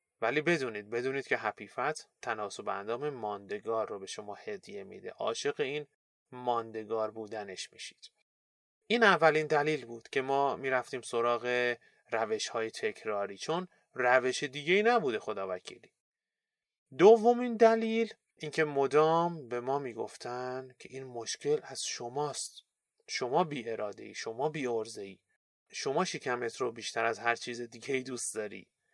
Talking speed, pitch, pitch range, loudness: 135 wpm, 130 Hz, 115-175 Hz, -32 LUFS